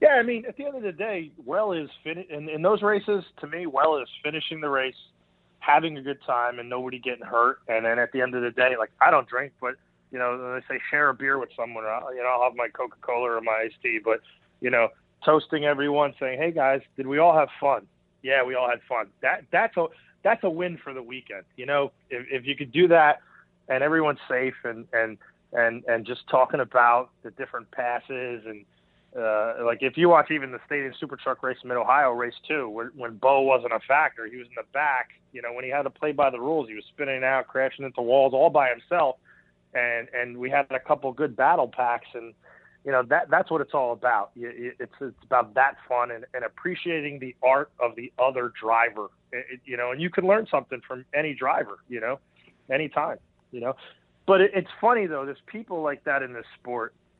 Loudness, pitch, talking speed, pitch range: -25 LUFS, 130 Hz, 235 wpm, 120-150 Hz